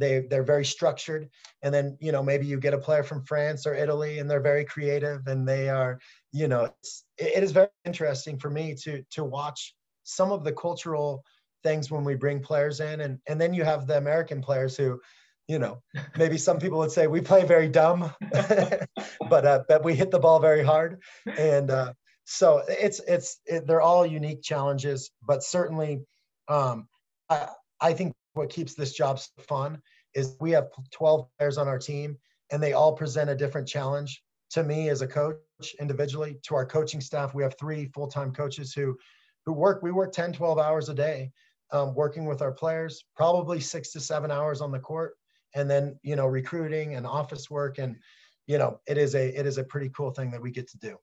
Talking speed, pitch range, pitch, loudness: 205 wpm, 140-160 Hz, 150 Hz, -27 LUFS